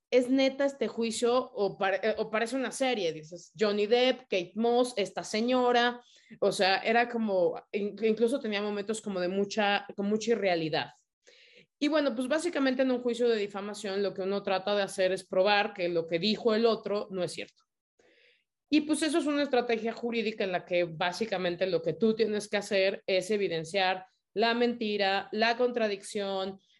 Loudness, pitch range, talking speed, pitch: -29 LUFS, 195-240 Hz, 175 wpm, 215 Hz